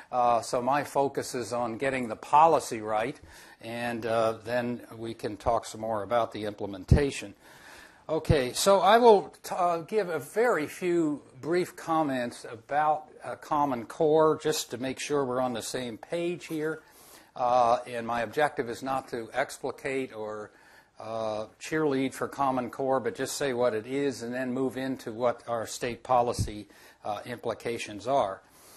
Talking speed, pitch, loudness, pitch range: 165 wpm, 125 Hz, -28 LUFS, 115-145 Hz